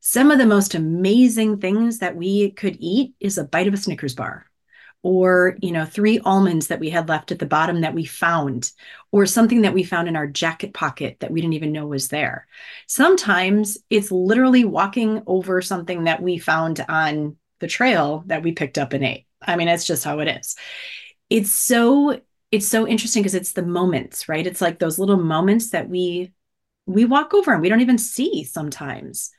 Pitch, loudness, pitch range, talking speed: 185 Hz, -19 LUFS, 160-215 Hz, 200 wpm